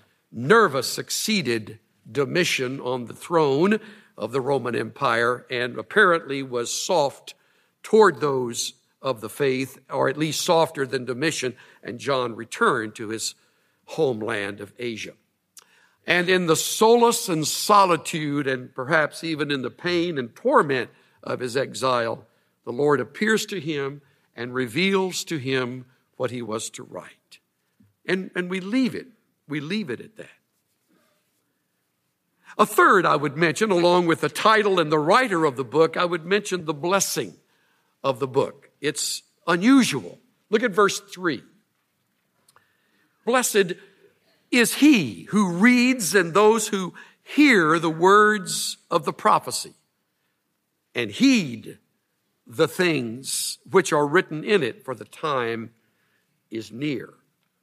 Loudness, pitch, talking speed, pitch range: -22 LUFS, 160 Hz, 135 wpm, 130-195 Hz